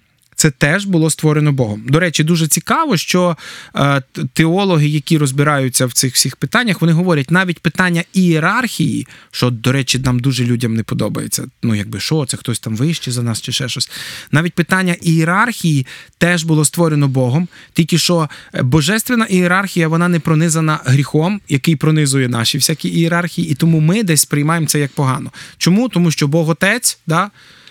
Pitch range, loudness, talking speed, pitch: 140-175 Hz, -15 LUFS, 165 wpm, 160 Hz